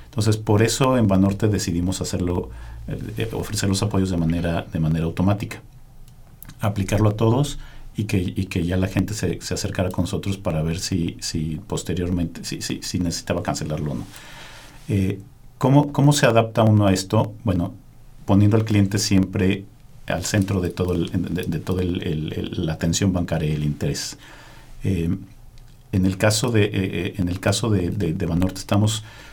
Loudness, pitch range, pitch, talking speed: -22 LUFS, 90-110 Hz, 100 Hz, 170 wpm